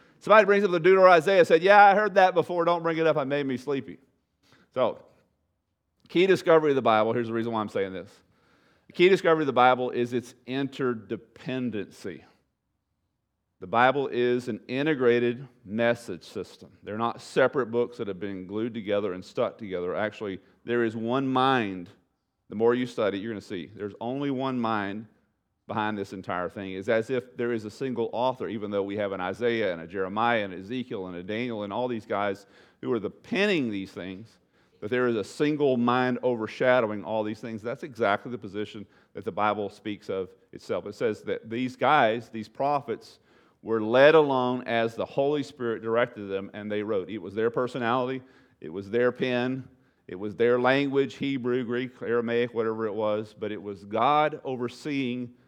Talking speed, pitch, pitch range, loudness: 195 wpm, 120 Hz, 105-130 Hz, -26 LUFS